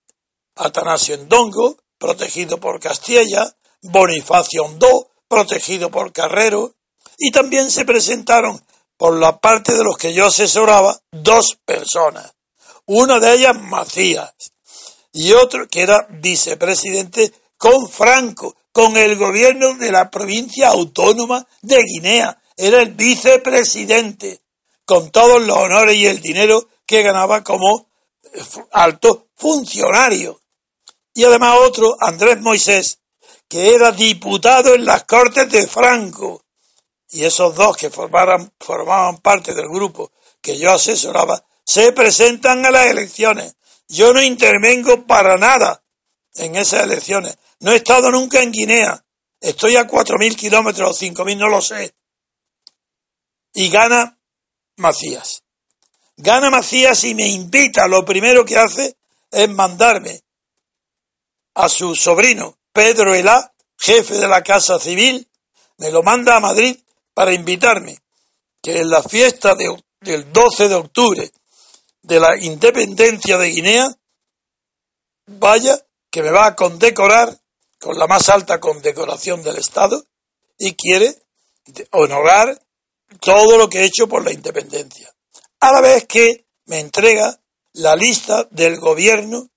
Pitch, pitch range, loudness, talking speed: 225 Hz, 195-255 Hz, -12 LUFS, 130 wpm